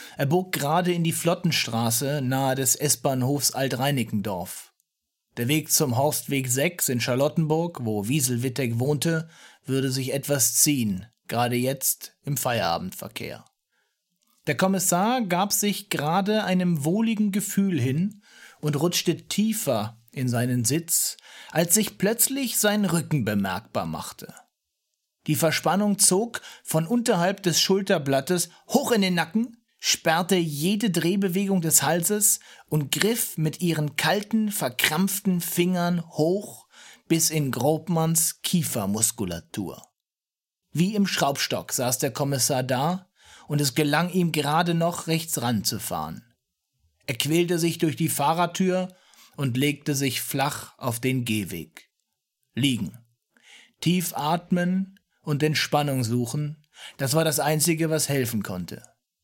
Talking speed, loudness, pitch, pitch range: 120 wpm, -24 LUFS, 160 Hz, 135-180 Hz